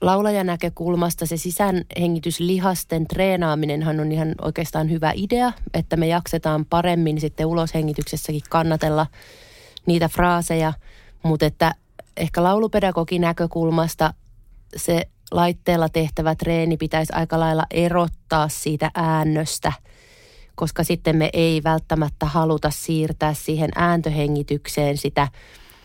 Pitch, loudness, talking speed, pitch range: 160 Hz, -21 LUFS, 100 wpm, 155-170 Hz